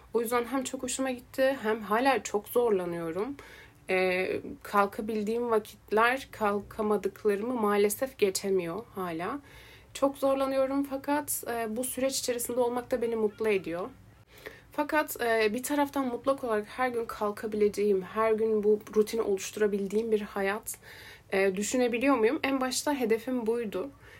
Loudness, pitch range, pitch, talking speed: -29 LUFS, 205-255 Hz, 225 Hz, 130 wpm